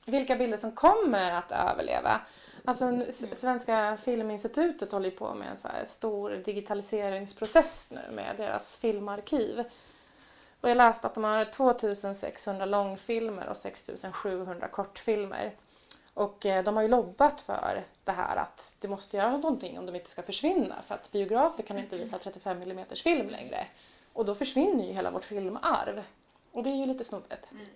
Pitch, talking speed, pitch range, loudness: 220 Hz, 160 wpm, 200-250 Hz, -30 LUFS